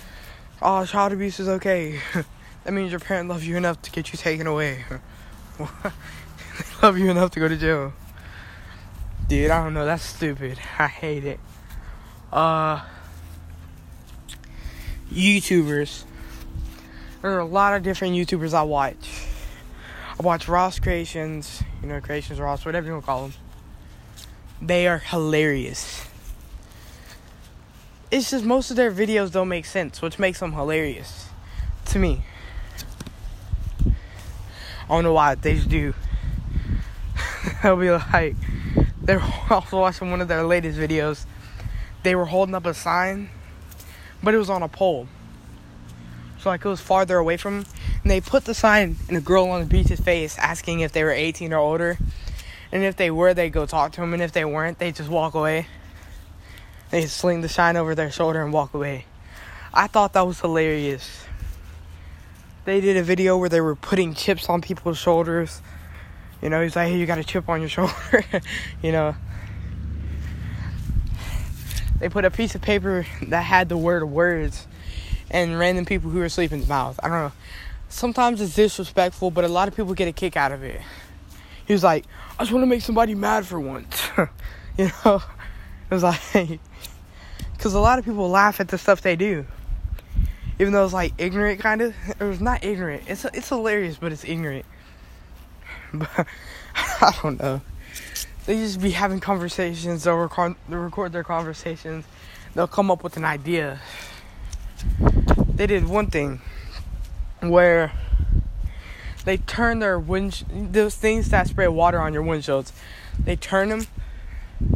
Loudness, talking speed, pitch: -22 LUFS, 165 wpm, 160 Hz